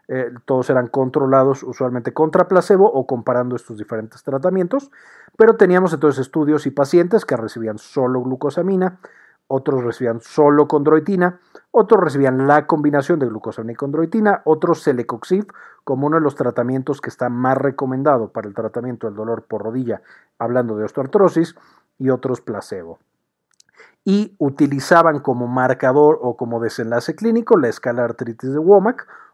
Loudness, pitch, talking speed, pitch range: -18 LUFS, 135 Hz, 145 wpm, 125-165 Hz